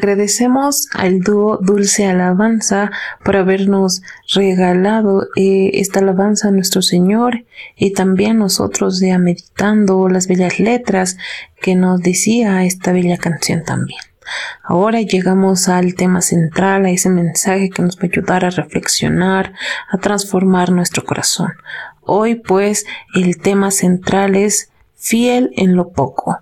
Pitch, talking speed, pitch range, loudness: 190 Hz, 130 wpm, 185-205 Hz, -14 LUFS